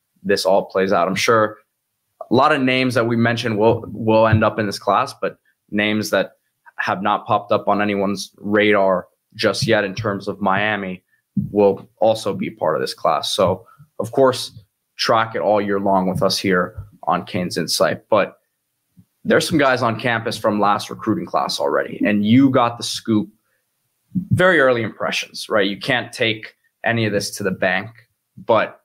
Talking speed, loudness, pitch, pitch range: 180 wpm, -19 LUFS, 105 Hz, 100-115 Hz